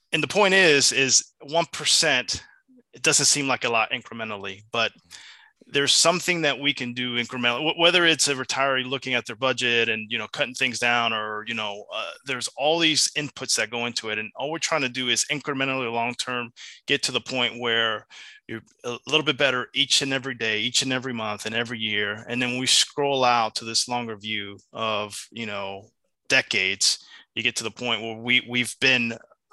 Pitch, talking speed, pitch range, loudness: 125 Hz, 205 wpm, 115-140 Hz, -22 LUFS